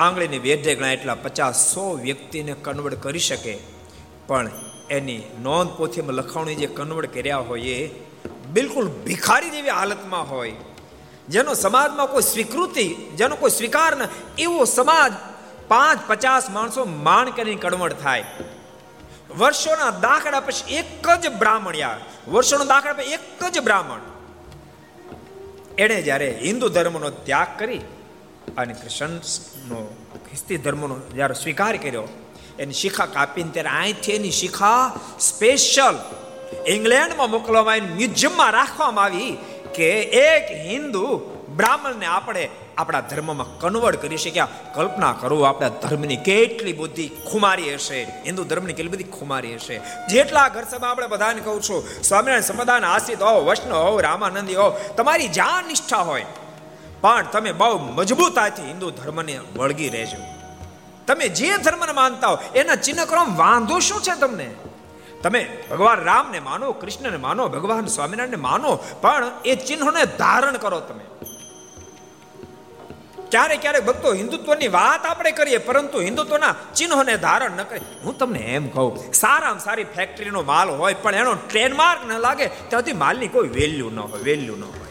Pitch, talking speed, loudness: 210 Hz, 140 wpm, -20 LUFS